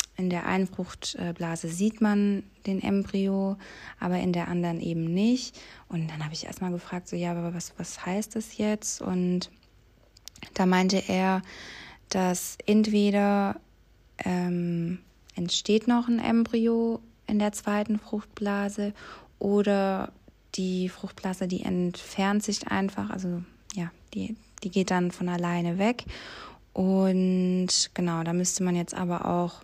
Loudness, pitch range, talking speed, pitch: -28 LUFS, 175-205 Hz, 135 wpm, 185 Hz